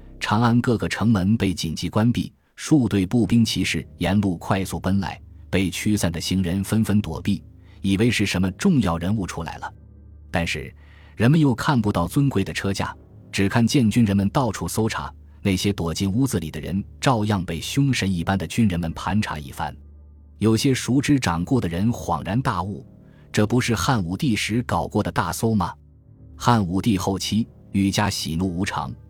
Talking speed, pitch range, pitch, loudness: 265 characters per minute, 85-110 Hz, 95 Hz, -22 LUFS